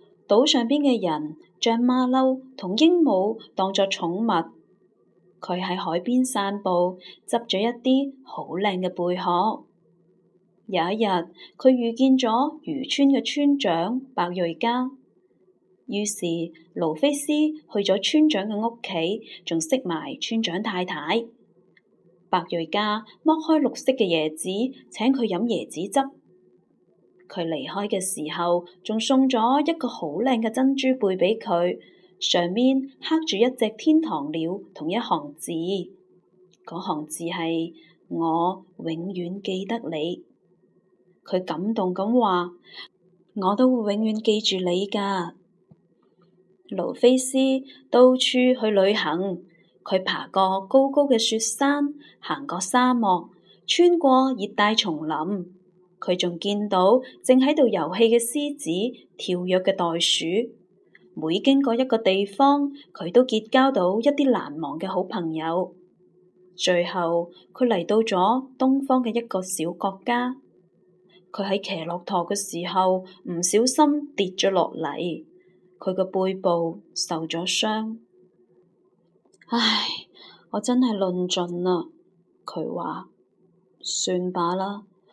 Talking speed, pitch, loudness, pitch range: 175 characters per minute, 195 Hz, -23 LUFS, 180-250 Hz